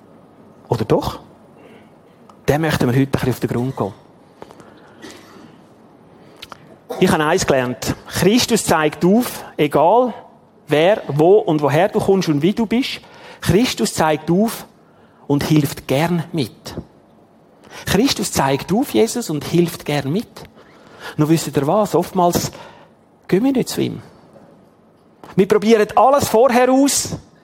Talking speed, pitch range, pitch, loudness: 130 wpm, 145-215 Hz, 170 Hz, -17 LUFS